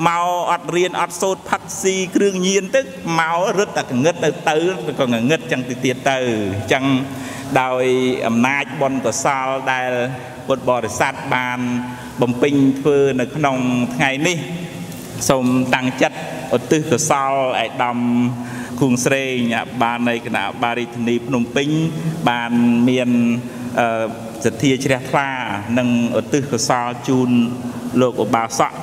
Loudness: -18 LUFS